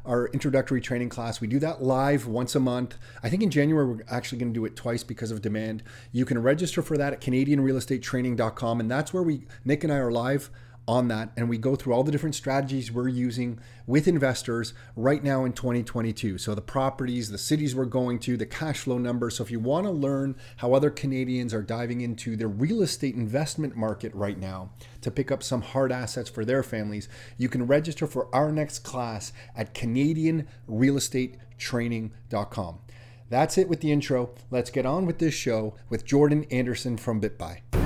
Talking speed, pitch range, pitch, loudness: 195 wpm, 115-135 Hz, 125 Hz, -27 LUFS